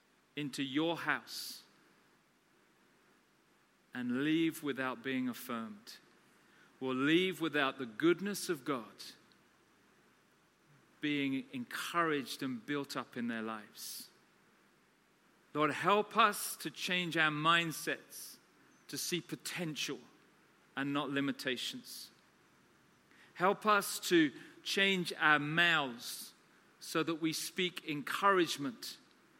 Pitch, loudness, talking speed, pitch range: 155 Hz, -35 LUFS, 95 wpm, 135-180 Hz